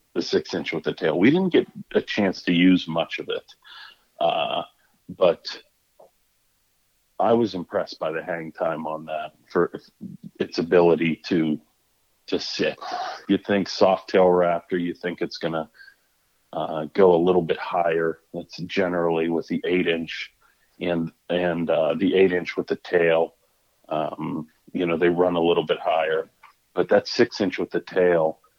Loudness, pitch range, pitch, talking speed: -23 LUFS, 80-95 Hz, 85 Hz, 170 wpm